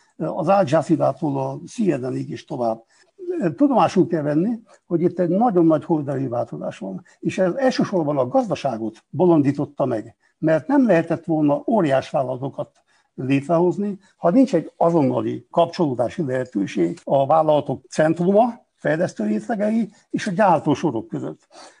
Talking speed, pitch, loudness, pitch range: 125 wpm, 165 Hz, -21 LUFS, 145-200 Hz